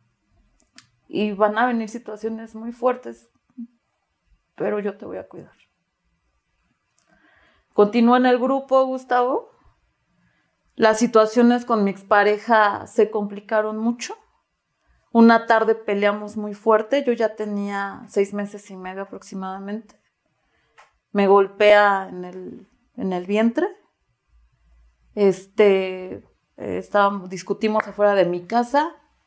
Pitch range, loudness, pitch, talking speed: 200-235 Hz, -20 LUFS, 215 Hz, 110 wpm